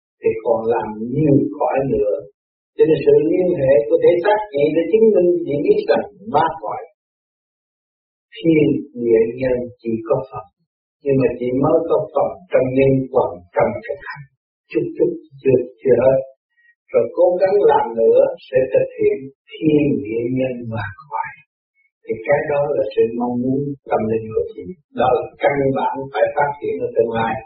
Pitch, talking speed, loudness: 165 Hz, 175 wpm, -18 LUFS